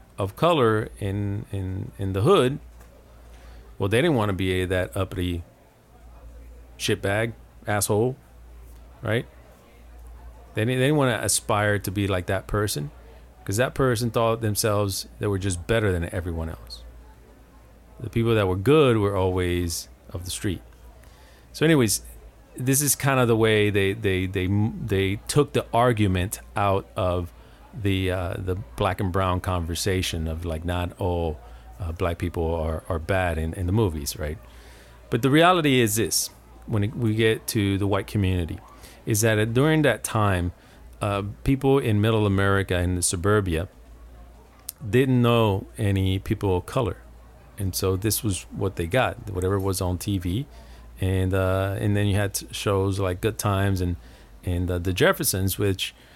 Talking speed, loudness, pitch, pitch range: 165 wpm, -24 LUFS, 95 Hz, 85-110 Hz